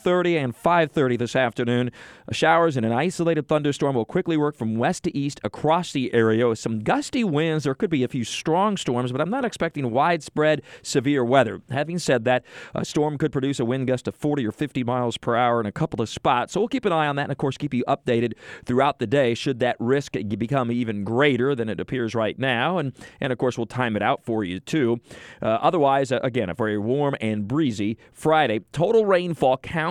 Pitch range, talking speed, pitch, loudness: 120-155 Hz, 225 wpm, 135 Hz, -23 LUFS